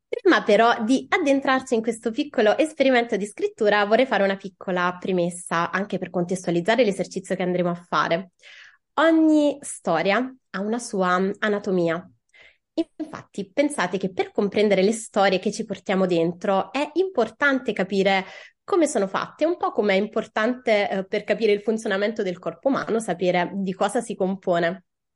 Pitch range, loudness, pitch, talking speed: 190-240 Hz, -23 LUFS, 205 Hz, 150 wpm